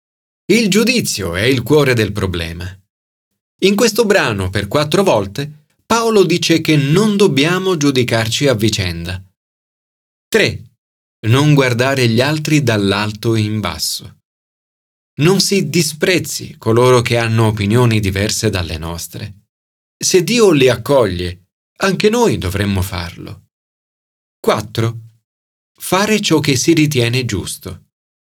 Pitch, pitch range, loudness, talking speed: 120 Hz, 100-160 Hz, -14 LUFS, 115 wpm